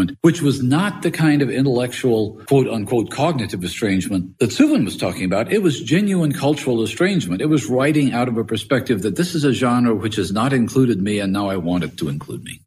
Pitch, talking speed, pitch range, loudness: 130 Hz, 220 wpm, 110-150 Hz, -19 LUFS